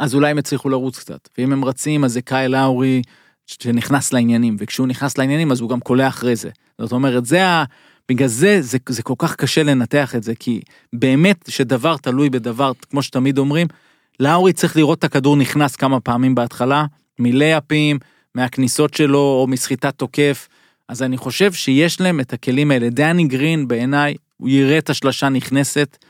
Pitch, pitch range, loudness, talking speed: 135 Hz, 125-145 Hz, -17 LUFS, 175 wpm